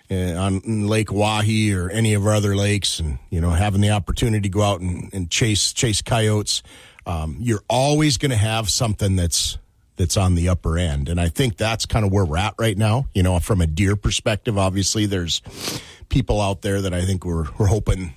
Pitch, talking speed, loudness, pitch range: 100 Hz, 210 wpm, -20 LUFS, 90-110 Hz